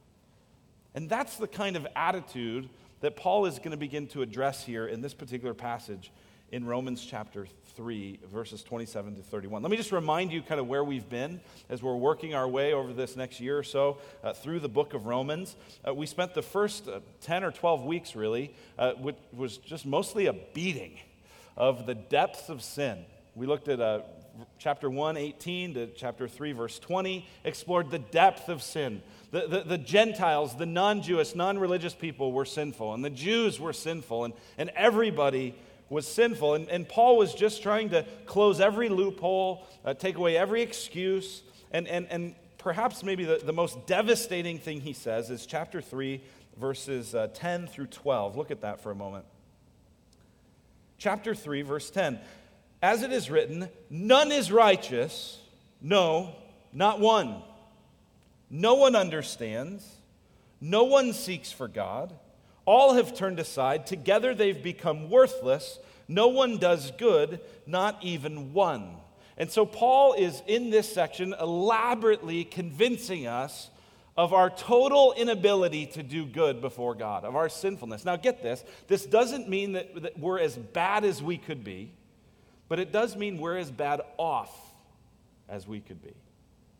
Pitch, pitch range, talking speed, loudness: 165 Hz, 130-195 Hz, 165 wpm, -28 LUFS